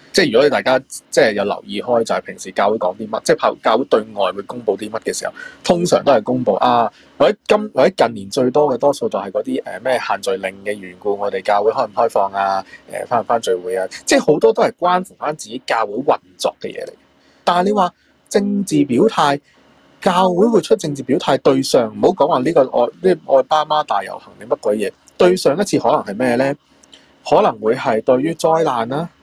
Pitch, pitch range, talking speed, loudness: 180 Hz, 135-215 Hz, 325 characters per minute, -17 LUFS